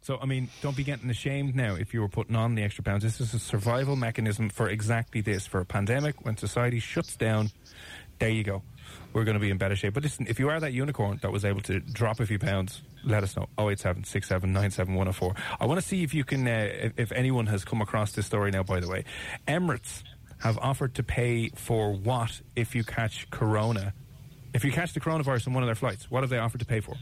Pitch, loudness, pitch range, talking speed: 115 Hz, -29 LUFS, 105-130 Hz, 260 wpm